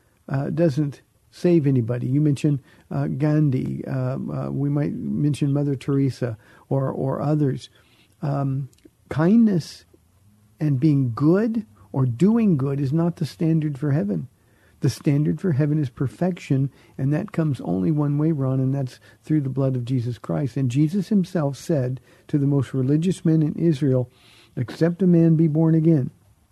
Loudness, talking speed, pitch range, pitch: -22 LUFS, 160 wpm, 130-160 Hz, 145 Hz